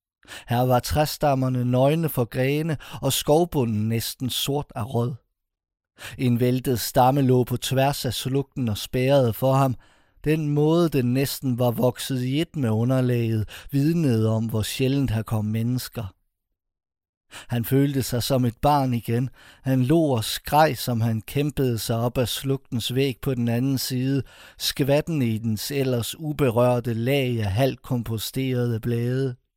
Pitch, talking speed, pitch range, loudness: 125 Hz, 150 wpm, 115-135 Hz, -23 LUFS